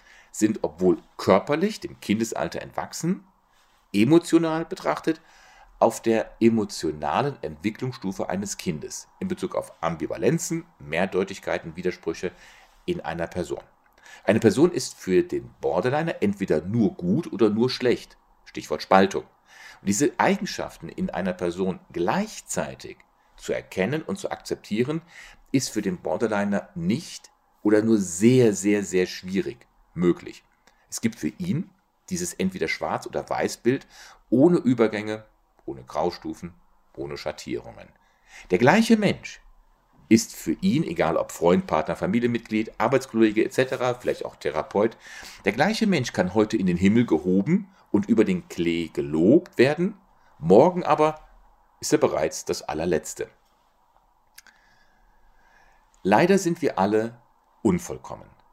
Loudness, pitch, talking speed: -24 LUFS, 130 Hz, 120 wpm